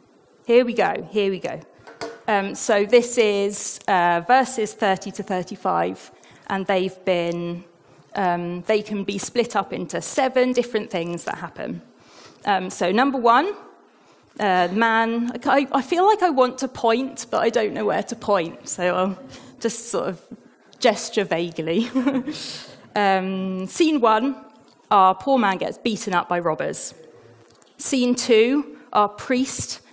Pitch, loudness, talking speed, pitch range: 215 Hz, -21 LUFS, 145 wpm, 190-250 Hz